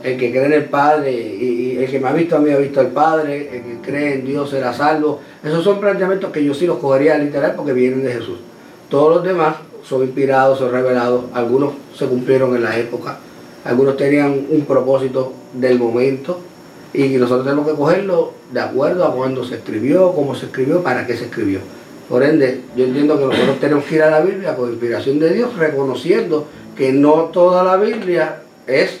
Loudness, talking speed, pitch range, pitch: -16 LUFS, 205 wpm, 125-155 Hz, 140 Hz